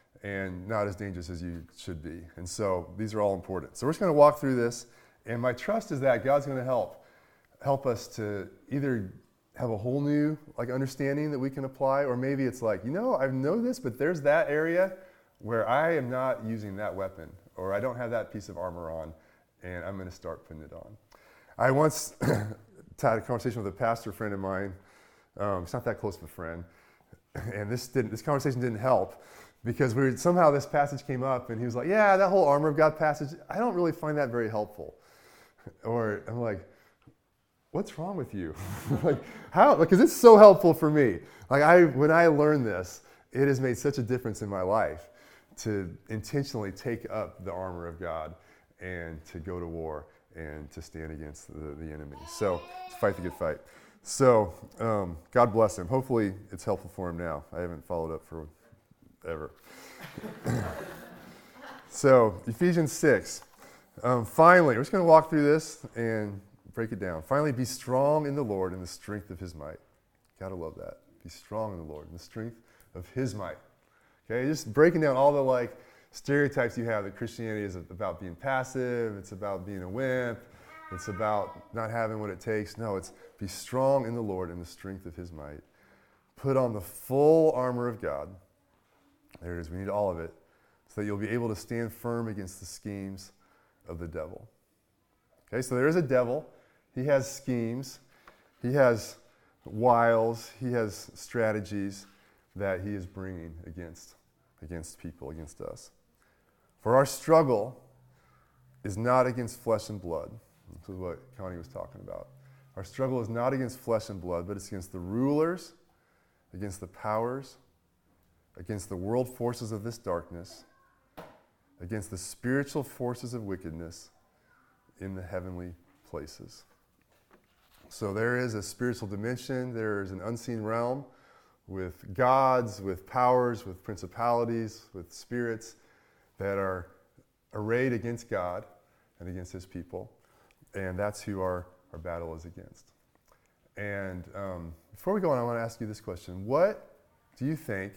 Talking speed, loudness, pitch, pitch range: 180 wpm, -28 LUFS, 110 Hz, 95-130 Hz